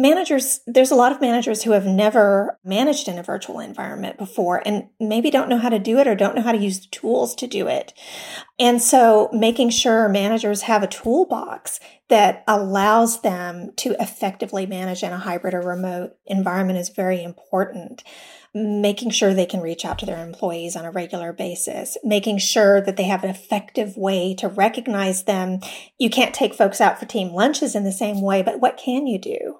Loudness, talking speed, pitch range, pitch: -20 LUFS, 200 wpm, 190-235 Hz, 210 Hz